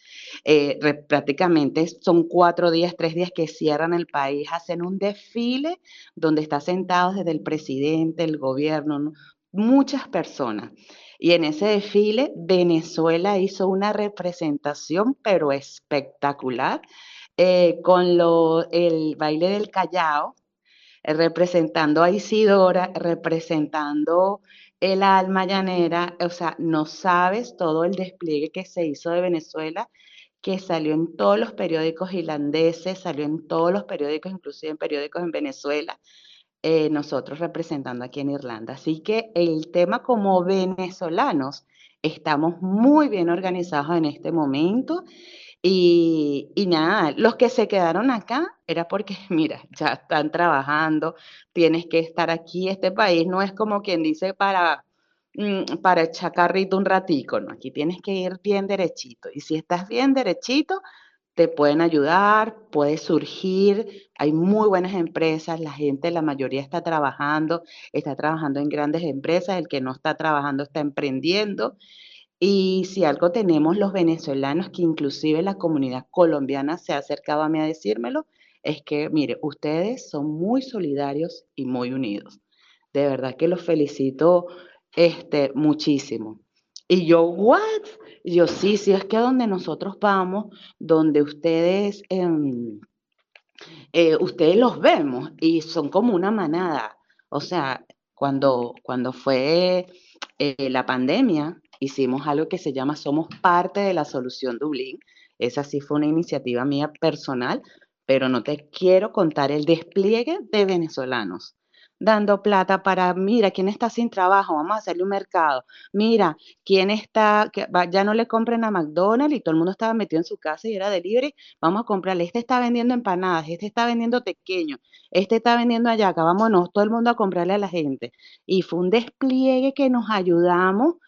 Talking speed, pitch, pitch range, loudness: 150 wpm, 170 Hz, 155-195 Hz, -22 LUFS